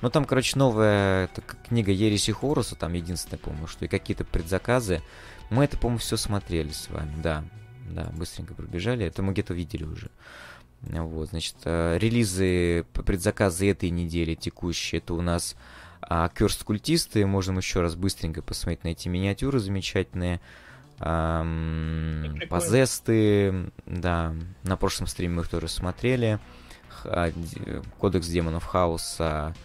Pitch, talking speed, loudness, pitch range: 90 Hz, 135 wpm, -27 LUFS, 85-105 Hz